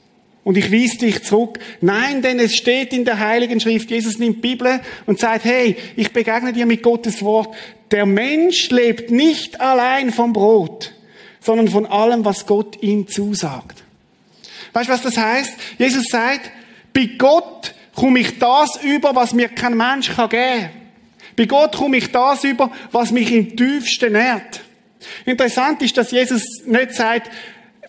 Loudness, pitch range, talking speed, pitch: -16 LUFS, 220-255 Hz, 165 wpm, 235 Hz